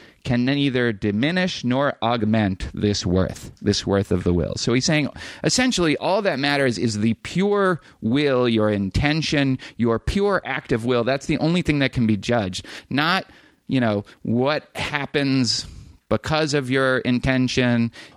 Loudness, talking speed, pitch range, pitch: -21 LUFS, 155 wpm, 110-145 Hz, 125 Hz